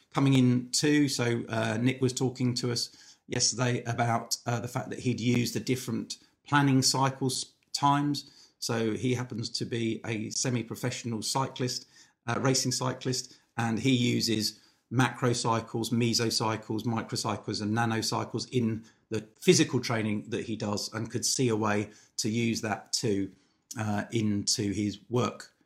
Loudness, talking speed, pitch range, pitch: -29 LUFS, 150 wpm, 110-125 Hz, 120 Hz